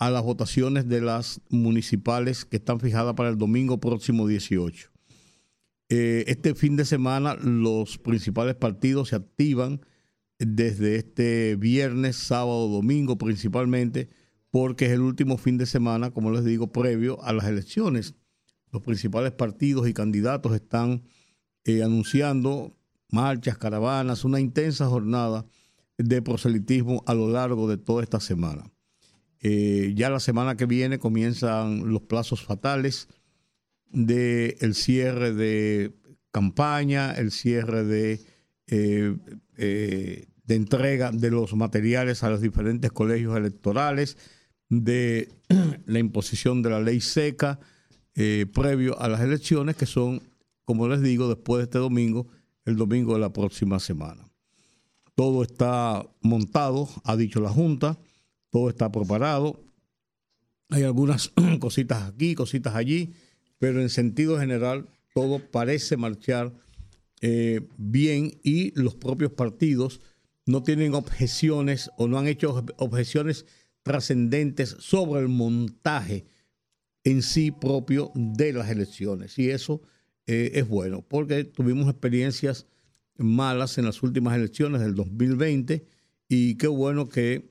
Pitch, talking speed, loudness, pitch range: 120 Hz, 130 wpm, -25 LUFS, 115-135 Hz